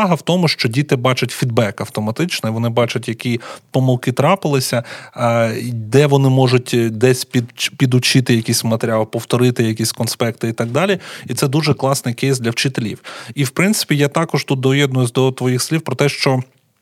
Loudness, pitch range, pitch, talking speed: -16 LUFS, 120-140 Hz, 130 Hz, 170 wpm